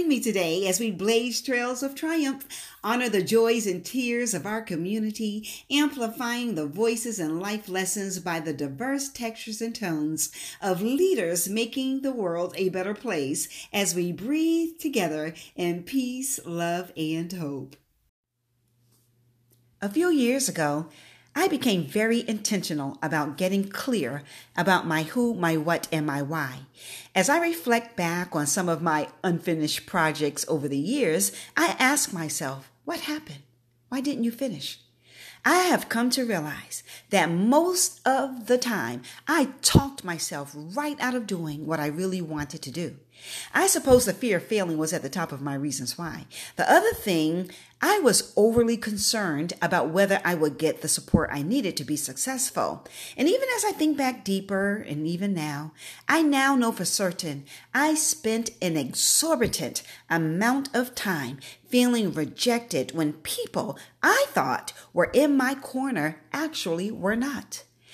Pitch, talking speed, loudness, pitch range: 190 Hz, 155 wpm, -26 LUFS, 155-245 Hz